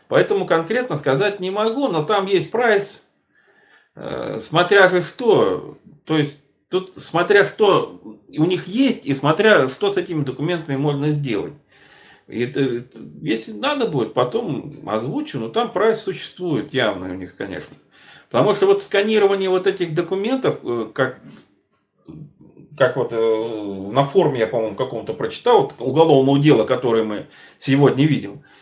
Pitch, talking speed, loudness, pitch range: 175 Hz, 135 wpm, -19 LUFS, 140-215 Hz